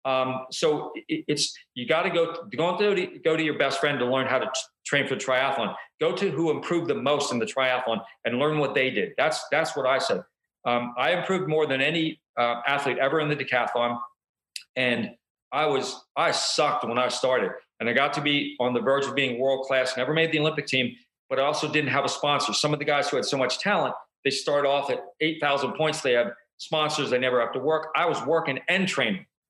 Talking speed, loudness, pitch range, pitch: 235 wpm, -25 LUFS, 130-155 Hz, 145 Hz